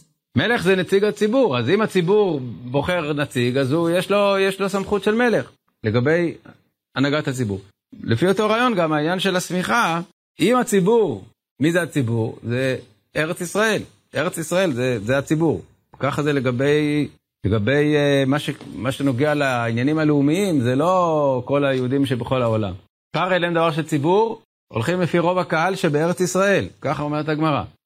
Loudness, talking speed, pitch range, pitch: -20 LUFS, 155 wpm, 135-180 Hz, 150 Hz